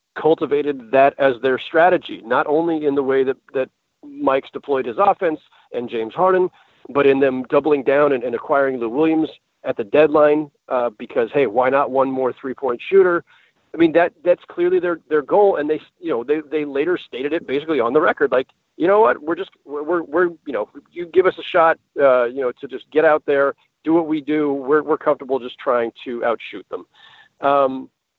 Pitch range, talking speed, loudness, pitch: 135-165 Hz, 215 wpm, -19 LUFS, 145 Hz